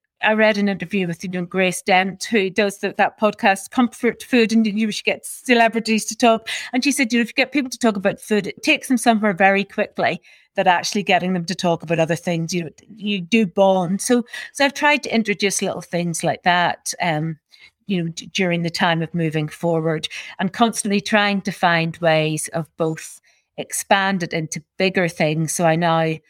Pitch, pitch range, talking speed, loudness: 195 Hz, 170-220 Hz, 210 wpm, -19 LUFS